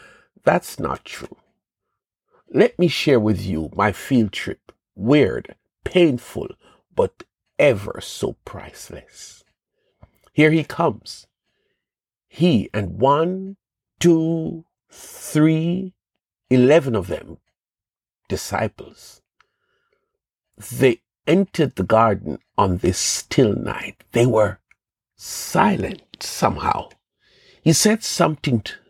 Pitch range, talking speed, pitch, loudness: 115-185 Hz, 95 wpm, 155 Hz, -20 LUFS